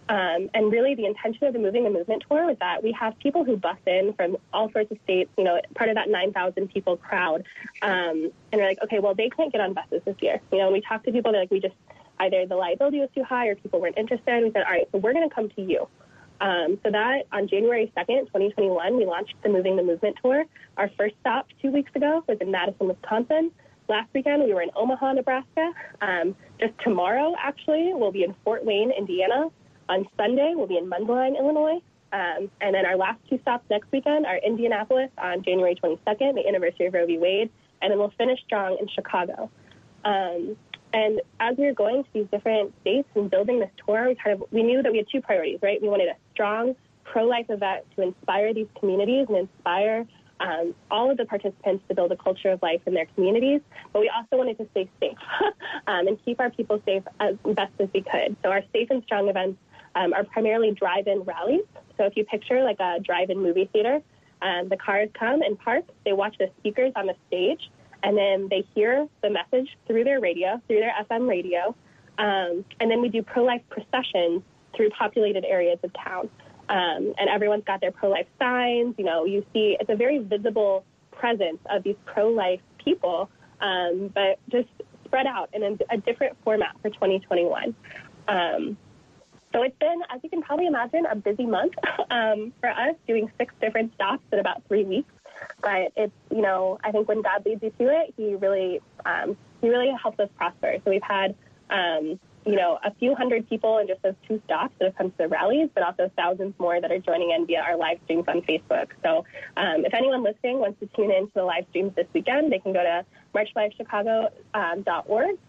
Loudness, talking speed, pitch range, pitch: -25 LUFS, 215 wpm, 190-250 Hz, 215 Hz